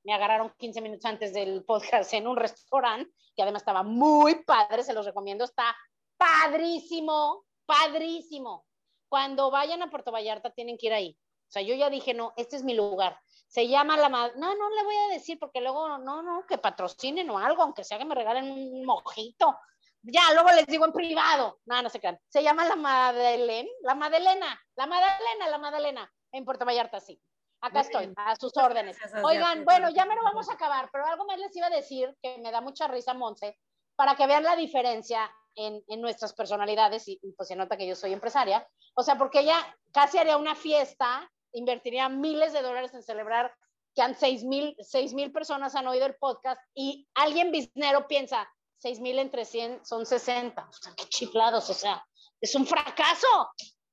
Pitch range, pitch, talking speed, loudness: 230-305 Hz, 265 Hz, 195 wpm, -27 LUFS